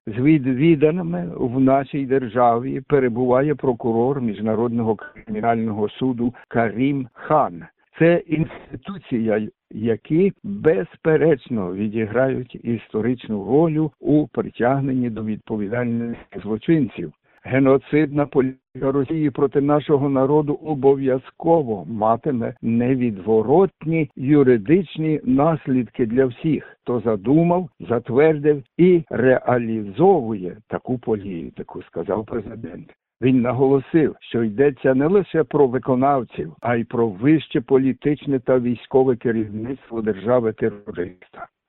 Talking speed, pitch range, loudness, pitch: 90 wpm, 115-150 Hz, -20 LUFS, 130 Hz